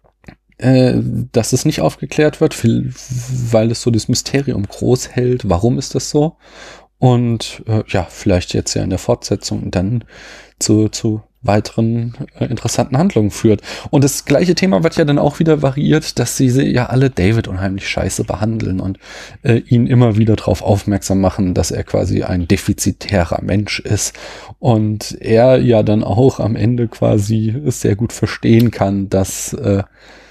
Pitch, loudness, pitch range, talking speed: 115 Hz, -15 LUFS, 100-125 Hz, 160 wpm